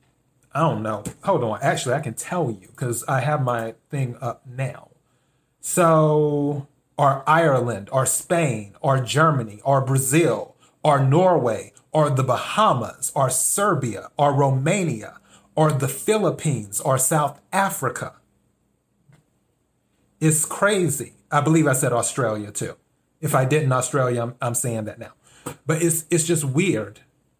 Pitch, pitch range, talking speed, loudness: 140 Hz, 125-160 Hz, 140 wpm, -21 LUFS